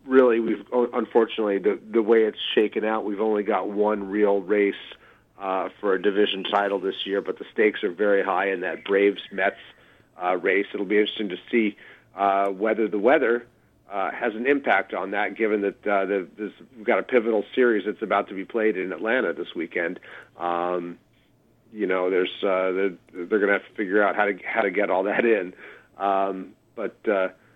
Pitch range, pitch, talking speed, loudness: 95-110 Hz, 100 Hz, 200 wpm, -24 LUFS